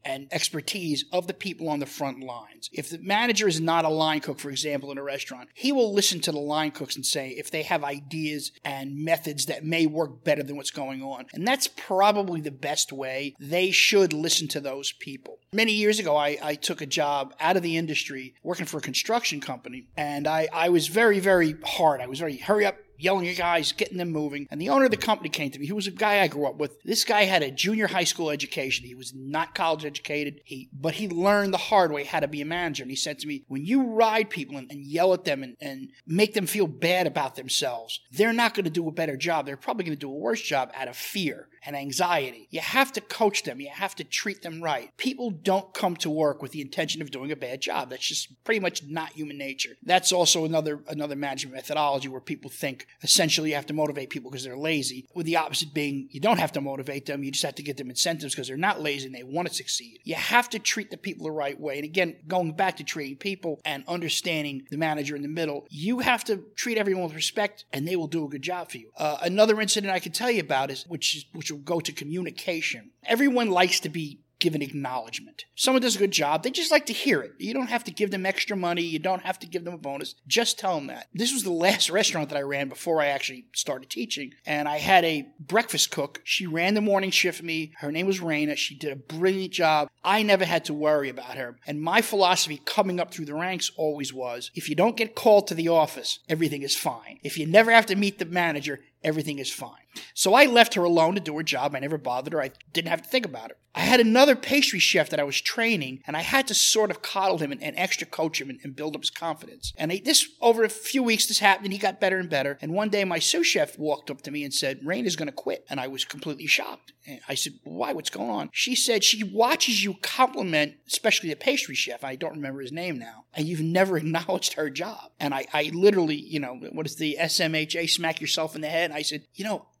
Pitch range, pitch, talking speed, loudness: 145-195 Hz, 160 Hz, 255 wpm, -25 LUFS